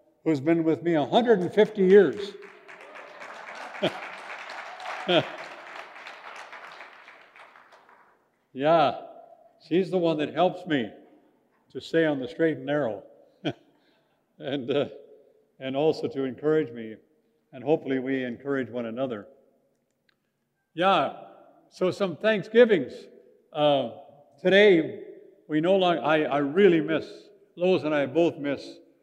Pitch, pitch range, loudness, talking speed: 165 Hz, 145-210 Hz, -25 LUFS, 105 wpm